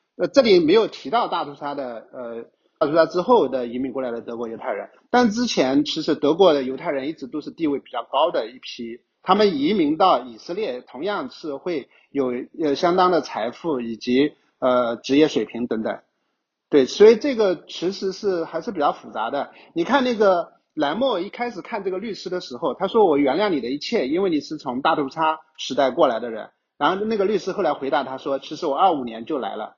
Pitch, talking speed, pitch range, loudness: 165 Hz, 310 characters per minute, 135-225 Hz, -21 LUFS